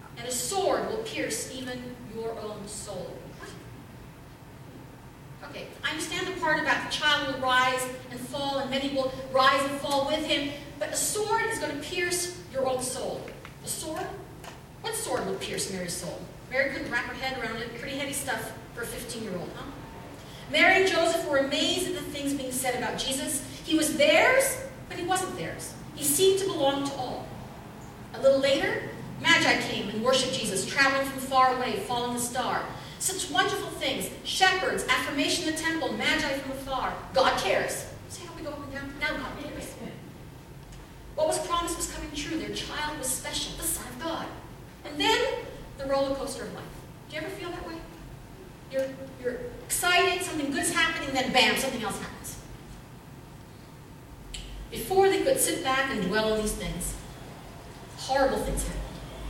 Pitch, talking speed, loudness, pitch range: 275 Hz, 180 wpm, -27 LUFS, 255-330 Hz